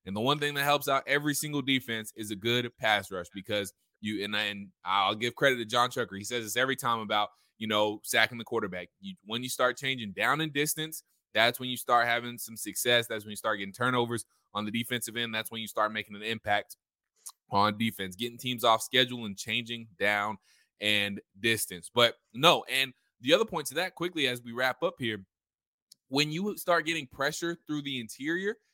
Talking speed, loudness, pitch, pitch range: 215 wpm, -29 LUFS, 120 Hz, 105-135 Hz